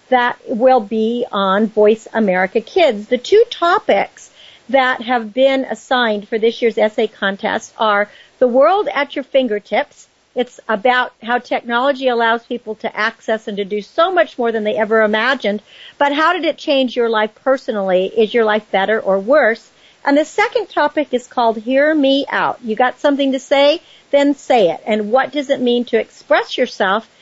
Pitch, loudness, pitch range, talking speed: 245 Hz, -16 LUFS, 220-280 Hz, 180 wpm